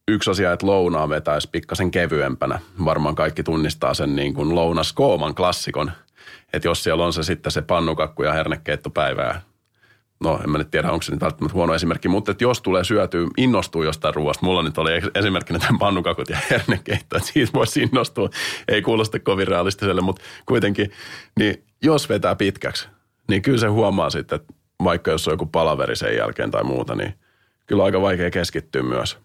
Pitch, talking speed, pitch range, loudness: 90 Hz, 180 wpm, 80-100 Hz, -21 LUFS